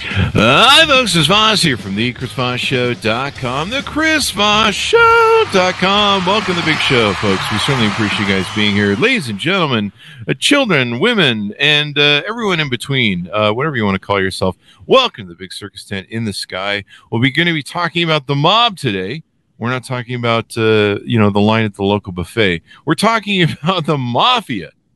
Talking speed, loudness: 195 wpm, -13 LUFS